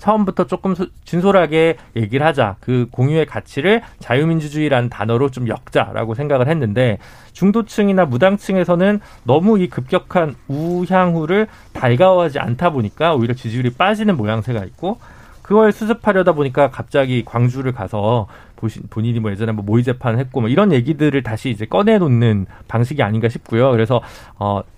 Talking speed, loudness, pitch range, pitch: 375 characters per minute, -17 LUFS, 115-180 Hz, 130 Hz